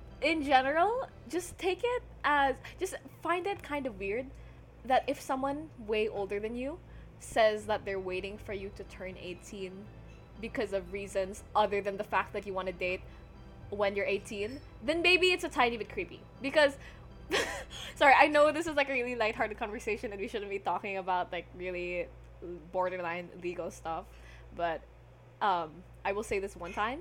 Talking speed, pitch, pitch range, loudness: 180 wpm, 210 Hz, 190-280 Hz, -32 LUFS